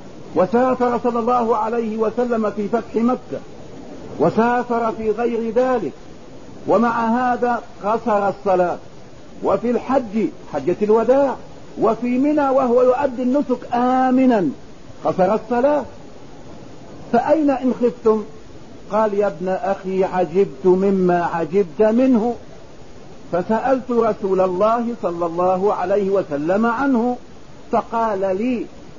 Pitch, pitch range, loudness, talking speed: 225 Hz, 195-245 Hz, -19 LUFS, 100 wpm